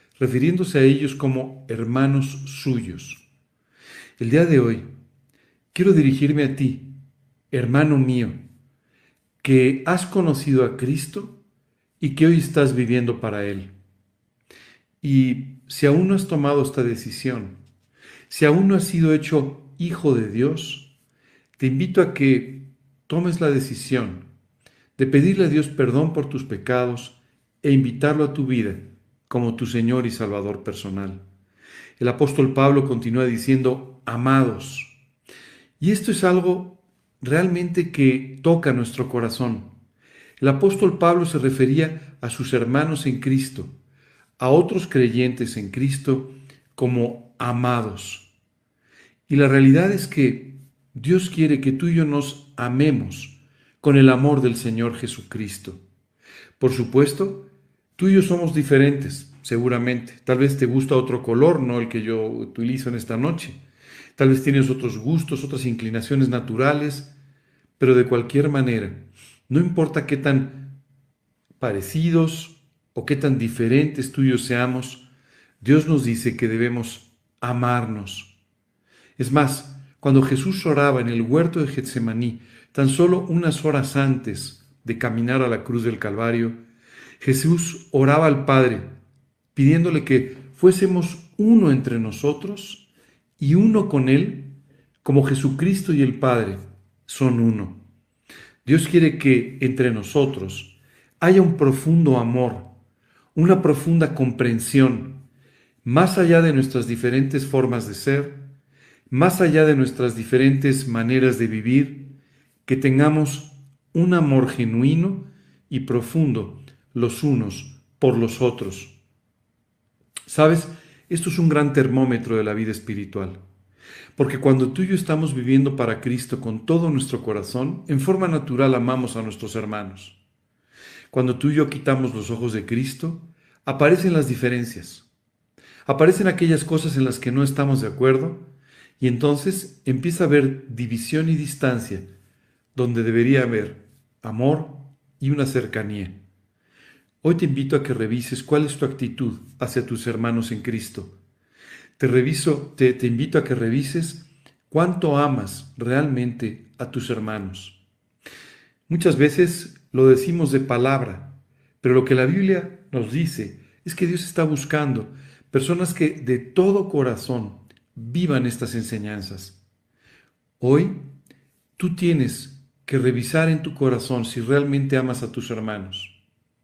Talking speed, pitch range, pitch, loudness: 135 wpm, 120-145 Hz, 135 Hz, -20 LUFS